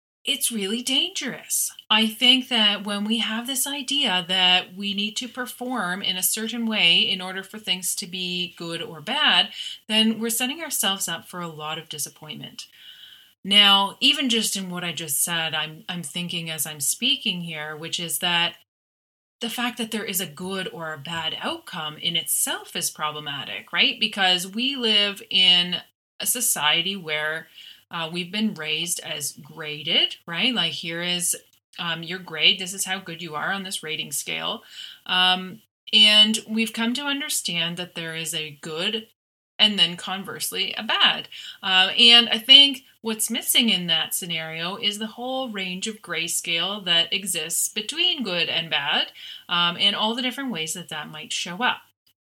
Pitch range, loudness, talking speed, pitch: 165-225 Hz, -21 LUFS, 175 wpm, 185 Hz